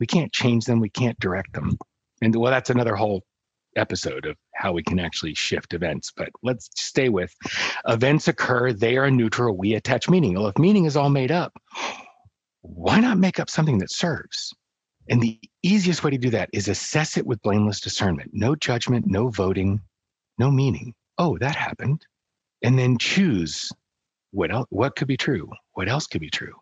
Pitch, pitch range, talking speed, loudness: 125 Hz, 105-145 Hz, 185 wpm, -23 LUFS